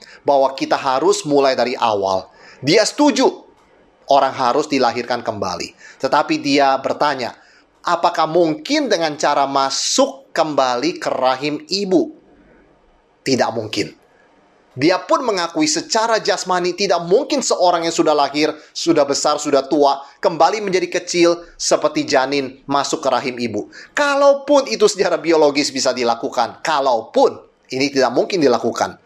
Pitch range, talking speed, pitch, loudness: 135-200 Hz, 125 wpm, 150 Hz, -17 LUFS